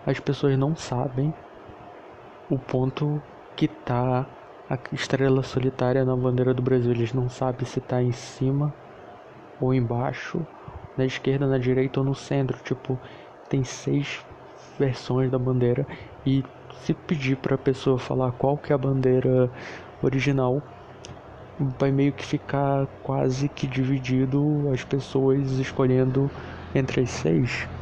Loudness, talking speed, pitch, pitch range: -25 LUFS, 135 wpm, 130 Hz, 125-135 Hz